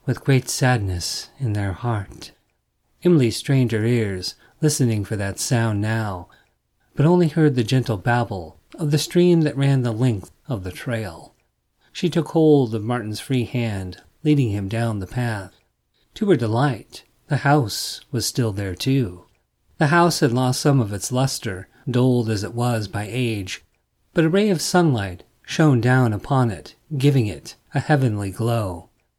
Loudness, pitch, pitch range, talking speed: -21 LUFS, 120 Hz, 100-140 Hz, 165 wpm